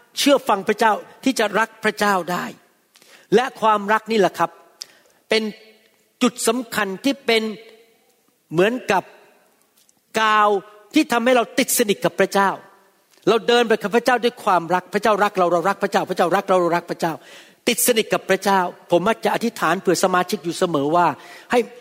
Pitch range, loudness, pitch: 185-230 Hz, -19 LUFS, 210 Hz